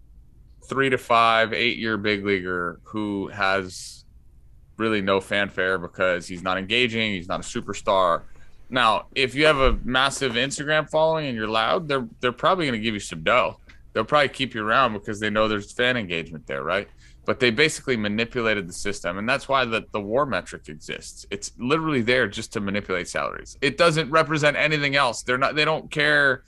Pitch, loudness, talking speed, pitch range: 115 Hz, -23 LUFS, 190 wpm, 100-135 Hz